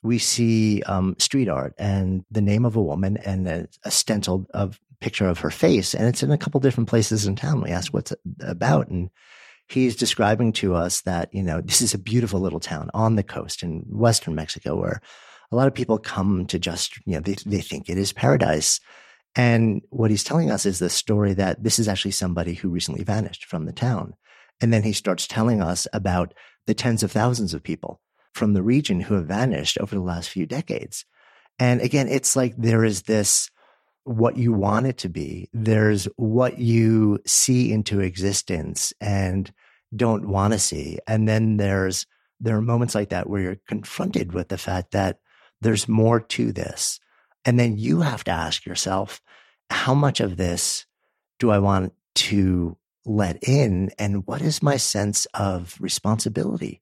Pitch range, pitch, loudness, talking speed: 95-115 Hz, 105 Hz, -22 LUFS, 190 wpm